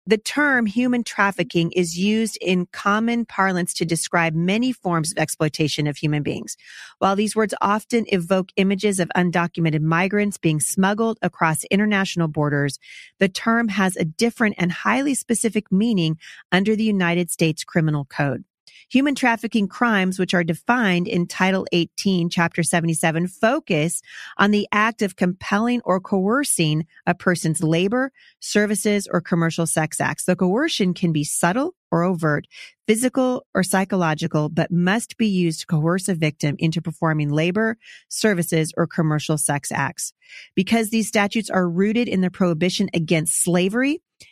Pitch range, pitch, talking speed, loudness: 165-215 Hz, 185 Hz, 150 wpm, -21 LUFS